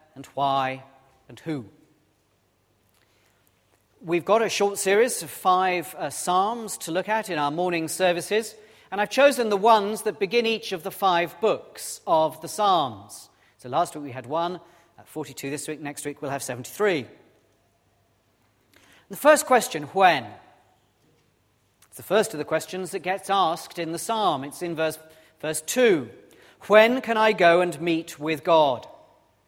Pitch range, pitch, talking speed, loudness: 135-195 Hz, 165 Hz, 160 wpm, -23 LUFS